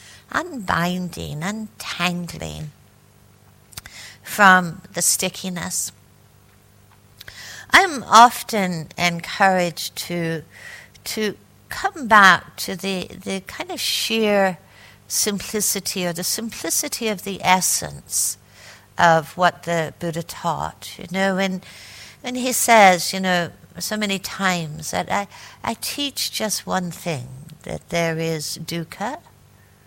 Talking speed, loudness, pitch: 105 wpm, -20 LUFS, 175 Hz